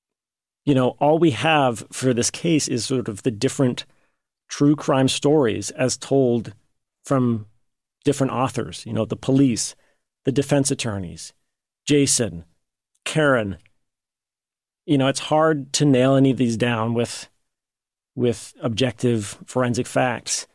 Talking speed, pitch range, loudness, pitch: 130 wpm, 120-140 Hz, -21 LUFS, 130 Hz